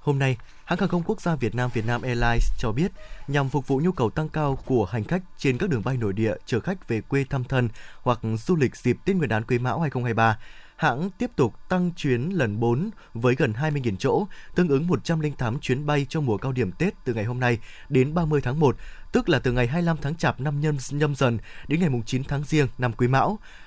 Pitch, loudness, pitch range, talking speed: 135 Hz, -25 LUFS, 120-160 Hz, 235 wpm